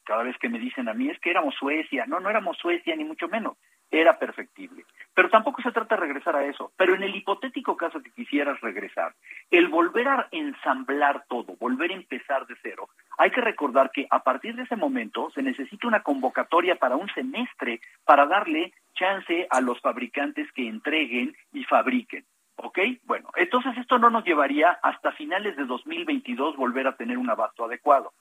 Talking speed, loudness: 190 wpm, -25 LUFS